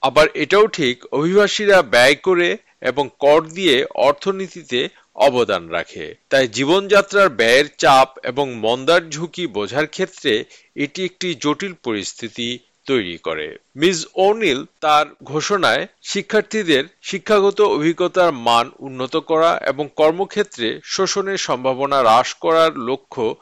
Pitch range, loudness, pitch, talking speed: 145-195 Hz, -17 LUFS, 170 Hz, 115 wpm